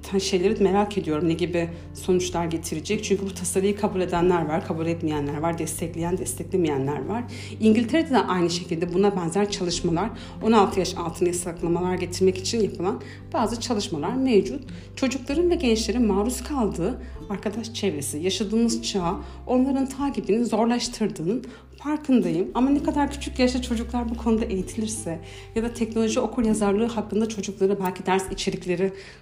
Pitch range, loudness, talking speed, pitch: 180-230 Hz, -24 LUFS, 140 wpm, 200 Hz